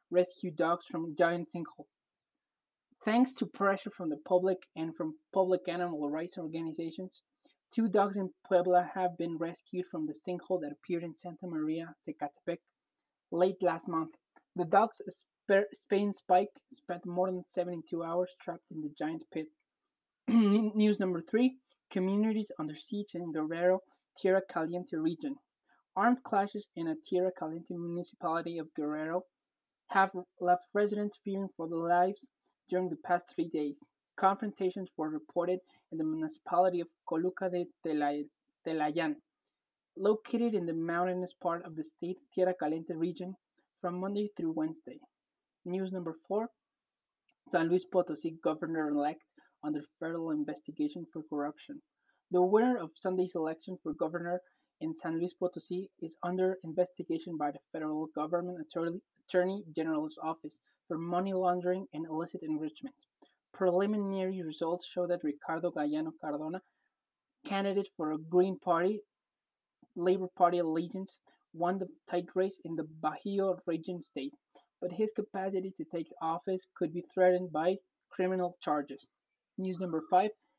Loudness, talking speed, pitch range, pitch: -34 LUFS, 140 wpm, 165-195 Hz, 180 Hz